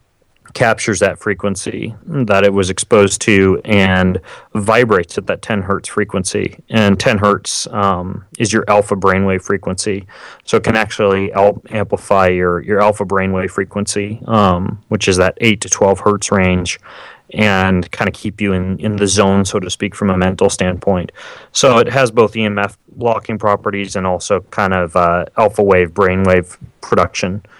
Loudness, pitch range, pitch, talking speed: -14 LUFS, 95-105 Hz, 100 Hz, 165 wpm